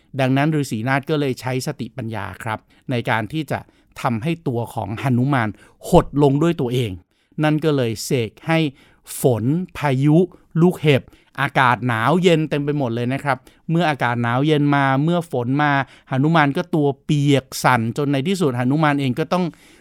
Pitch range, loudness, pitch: 125-155 Hz, -20 LUFS, 140 Hz